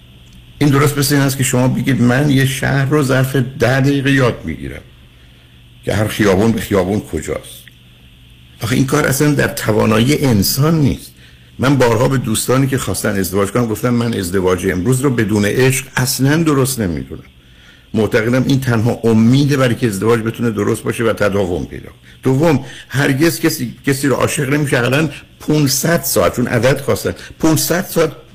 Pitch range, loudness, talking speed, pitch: 100-140 Hz, -15 LUFS, 165 wpm, 125 Hz